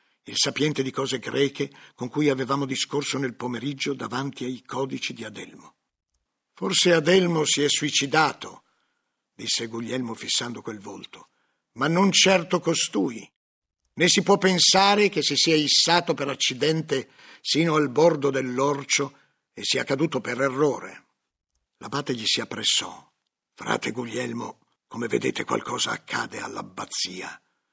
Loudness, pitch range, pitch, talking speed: -23 LUFS, 130-165 Hz, 140 Hz, 130 wpm